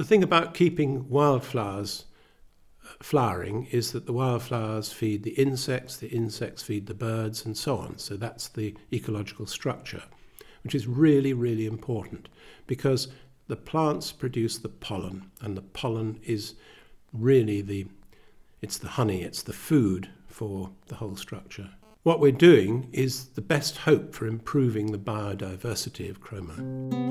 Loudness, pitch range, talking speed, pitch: -27 LUFS, 105-135 Hz, 145 wpm, 115 Hz